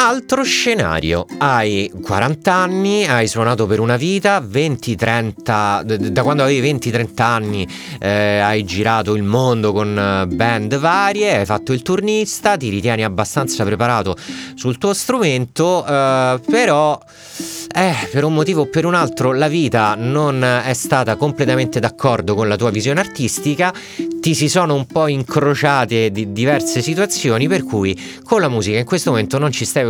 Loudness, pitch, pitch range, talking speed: -16 LUFS, 130 Hz, 110-160 Hz, 155 wpm